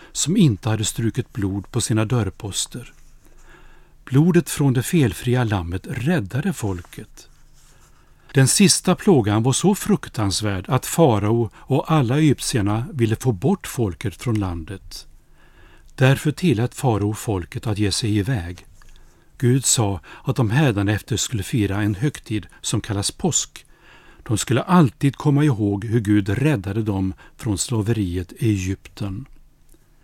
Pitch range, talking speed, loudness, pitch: 100-140 Hz, 130 wpm, -20 LUFS, 115 Hz